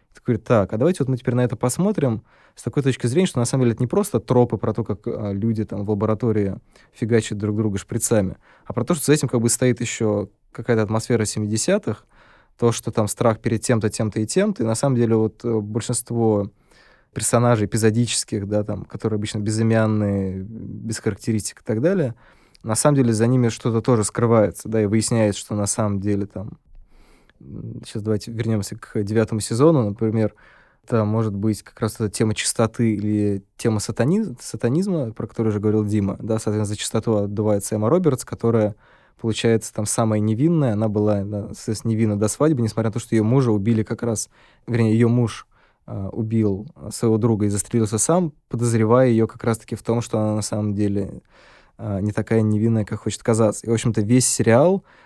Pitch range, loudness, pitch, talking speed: 105-120 Hz, -21 LUFS, 110 Hz, 185 wpm